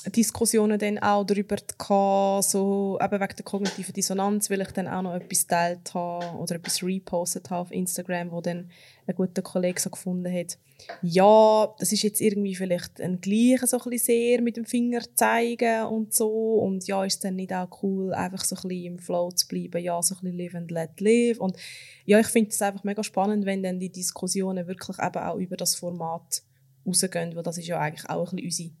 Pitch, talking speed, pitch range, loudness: 190 Hz, 210 wpm, 175-205 Hz, -25 LUFS